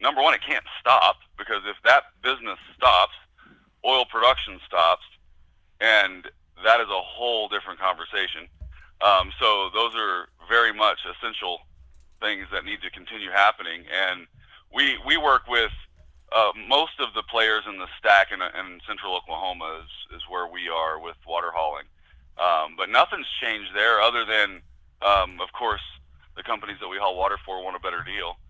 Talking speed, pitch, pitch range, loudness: 165 wpm, 85 Hz, 75-100 Hz, -23 LUFS